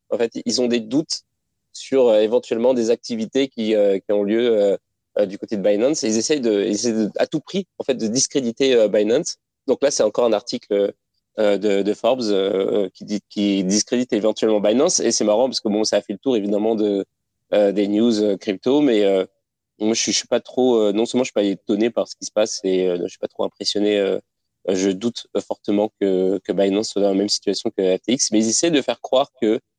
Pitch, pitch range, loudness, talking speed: 105 Hz, 100-125 Hz, -20 LUFS, 240 wpm